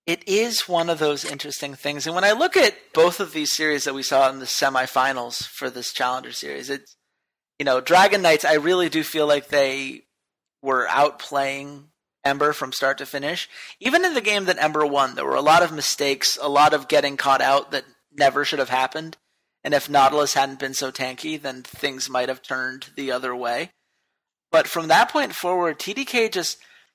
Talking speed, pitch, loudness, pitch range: 200 wpm, 145 Hz, -21 LUFS, 135-160 Hz